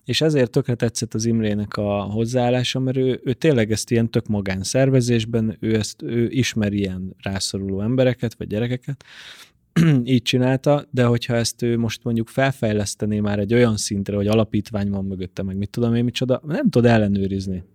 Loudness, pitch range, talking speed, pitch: -21 LUFS, 105-125 Hz, 165 wpm, 115 Hz